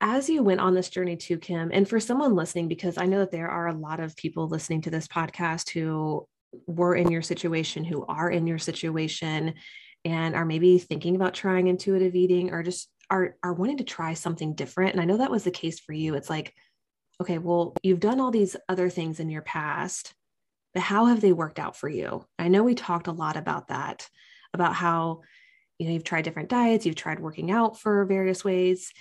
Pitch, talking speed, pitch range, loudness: 175 Hz, 220 wpm, 165-185 Hz, -26 LUFS